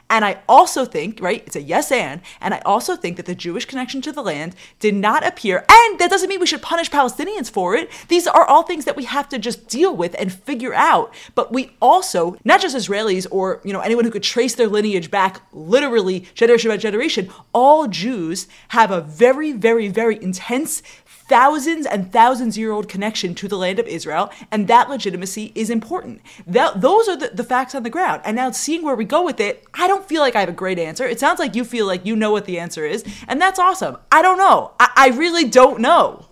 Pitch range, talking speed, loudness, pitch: 200-290 Hz, 230 wpm, -17 LUFS, 235 Hz